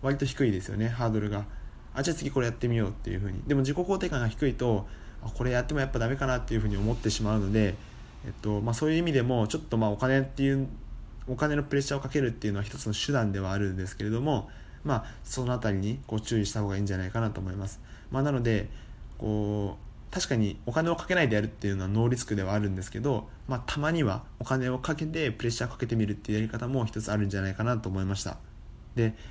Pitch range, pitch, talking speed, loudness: 105-130 Hz, 115 Hz, 520 characters per minute, -30 LUFS